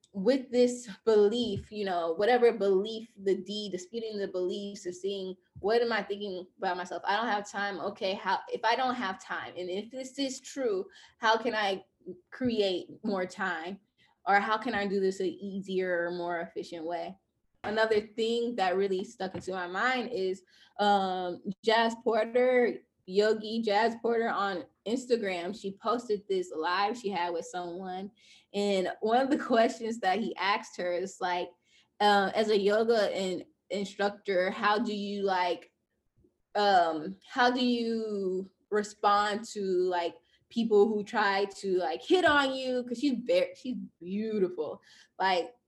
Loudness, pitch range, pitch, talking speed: -30 LUFS, 185-225 Hz, 200 Hz, 160 wpm